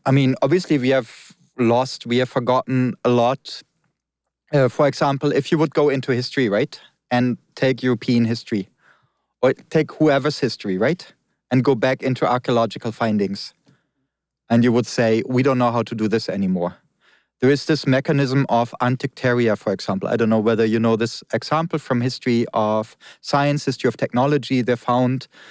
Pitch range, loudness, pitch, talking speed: 115-140 Hz, -20 LUFS, 125 Hz, 170 wpm